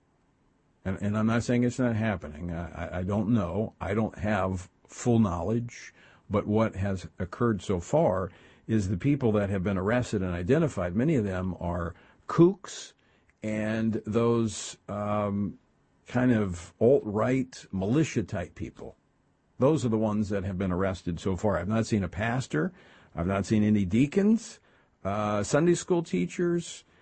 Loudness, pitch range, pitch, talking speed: -28 LUFS, 95-120 Hz, 105 Hz, 160 wpm